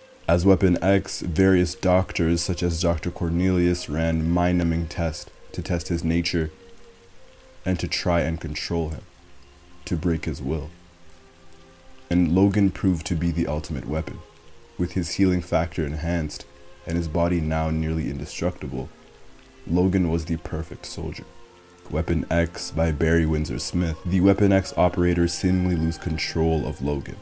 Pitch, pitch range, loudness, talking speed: 85 Hz, 80-90 Hz, -24 LUFS, 145 wpm